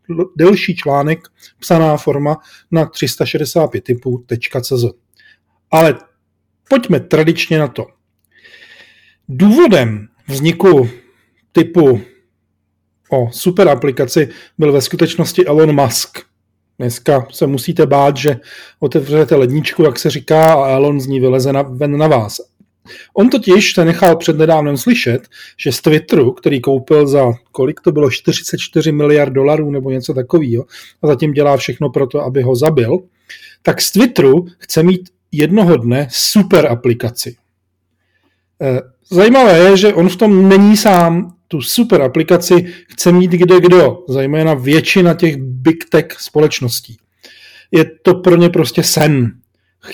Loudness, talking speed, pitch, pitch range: -12 LUFS, 130 wpm, 155 Hz, 135-175 Hz